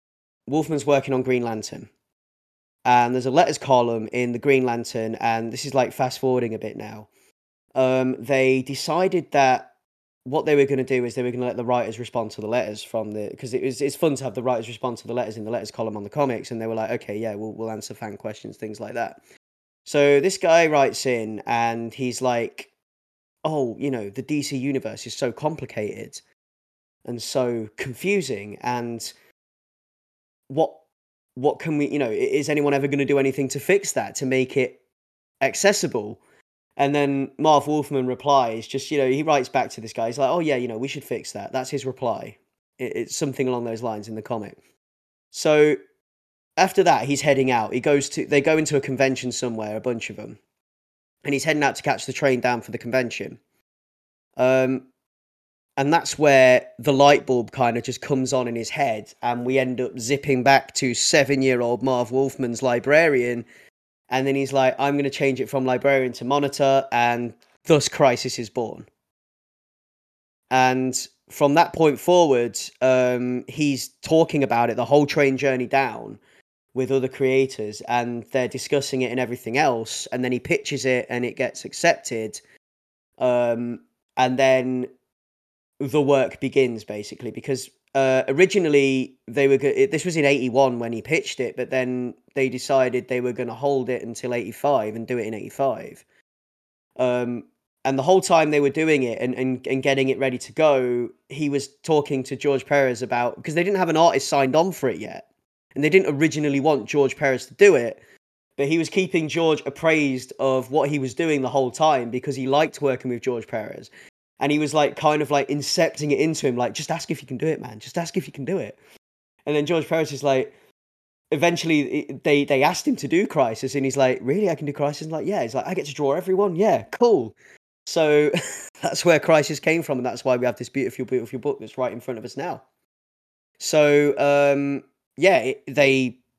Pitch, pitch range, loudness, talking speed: 130 Hz, 120-145 Hz, -22 LUFS, 205 wpm